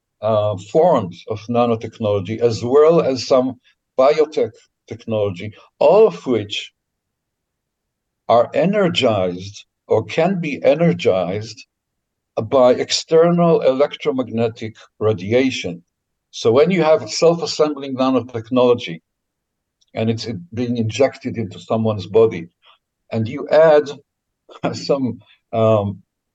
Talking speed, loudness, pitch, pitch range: 95 wpm, -17 LUFS, 115 Hz, 105-140 Hz